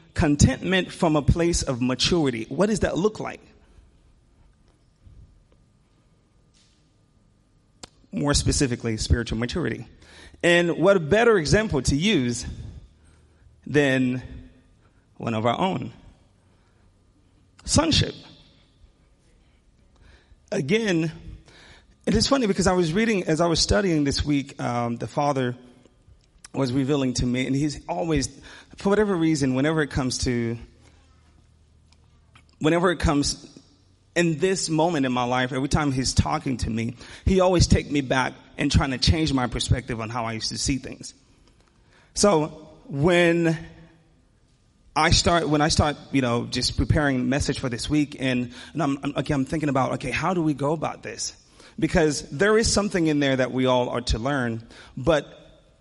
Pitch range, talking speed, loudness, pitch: 115-160 Hz, 145 wpm, -23 LUFS, 135 Hz